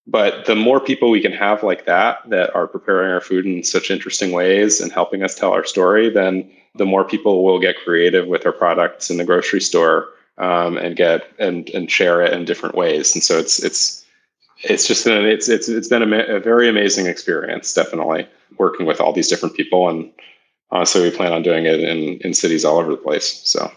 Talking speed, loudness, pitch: 220 wpm, -16 LUFS, 105 Hz